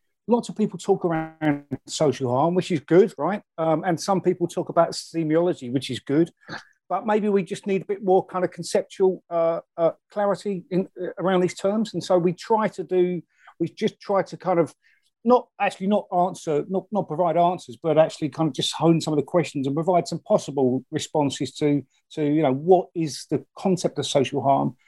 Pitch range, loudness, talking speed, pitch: 155-190 Hz, -23 LUFS, 205 wpm, 175 Hz